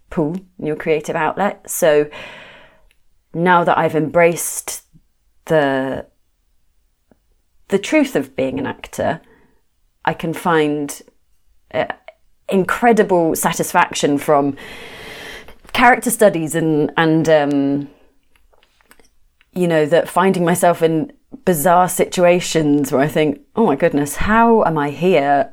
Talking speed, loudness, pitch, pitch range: 110 wpm, -16 LUFS, 165 Hz, 145-185 Hz